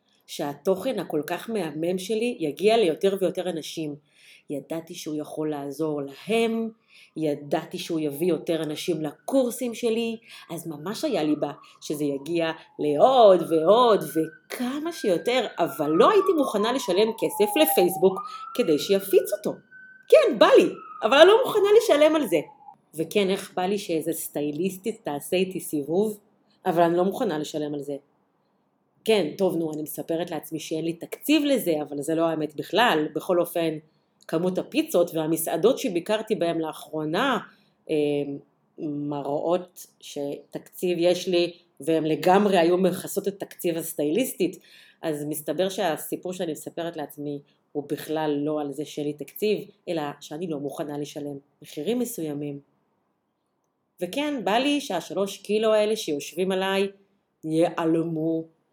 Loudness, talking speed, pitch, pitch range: -25 LUFS, 135 wpm, 170 Hz, 155-210 Hz